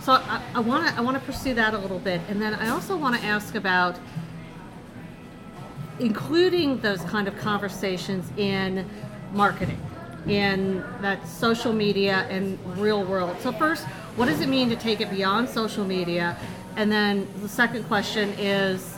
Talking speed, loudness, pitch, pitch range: 160 wpm, -25 LUFS, 205 Hz, 190-230 Hz